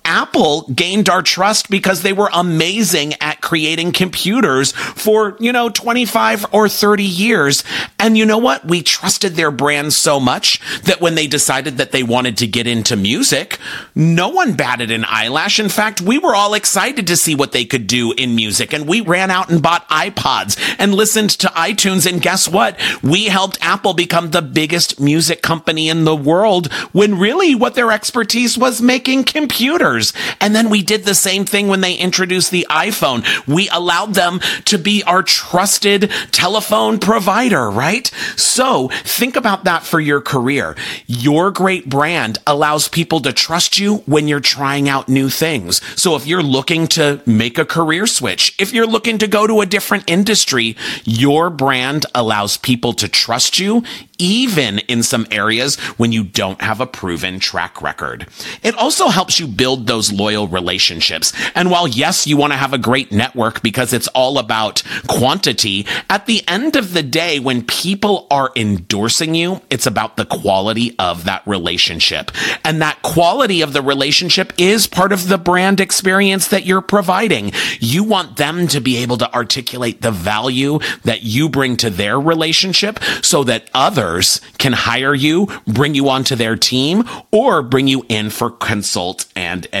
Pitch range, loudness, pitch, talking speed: 130-200 Hz, -14 LUFS, 165 Hz, 175 wpm